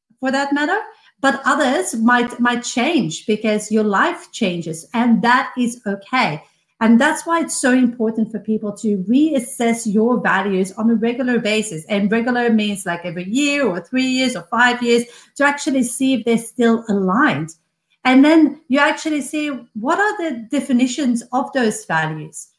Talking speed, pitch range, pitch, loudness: 165 wpm, 215-270 Hz, 240 Hz, -18 LUFS